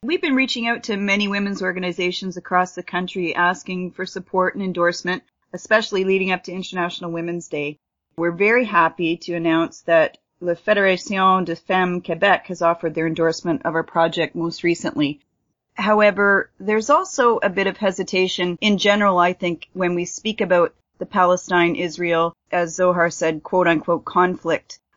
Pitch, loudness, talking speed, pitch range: 180 Hz, -20 LUFS, 160 wpm, 170-195 Hz